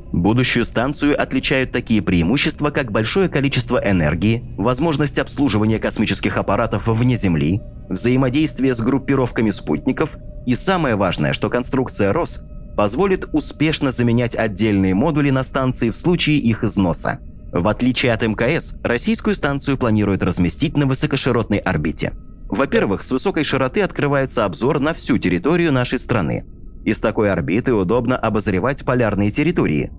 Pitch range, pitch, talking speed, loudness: 110-145 Hz, 125 Hz, 130 wpm, -18 LUFS